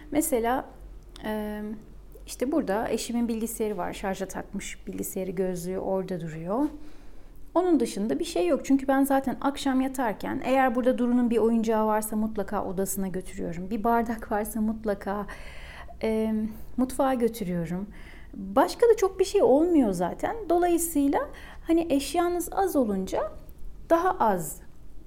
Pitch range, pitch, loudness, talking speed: 205-280 Hz, 235 Hz, -27 LUFS, 120 wpm